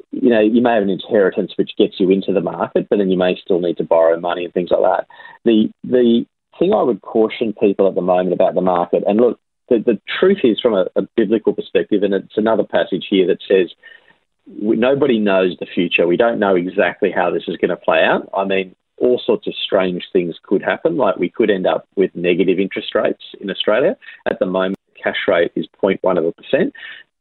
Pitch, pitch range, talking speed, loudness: 100 Hz, 90-120 Hz, 225 wpm, -17 LUFS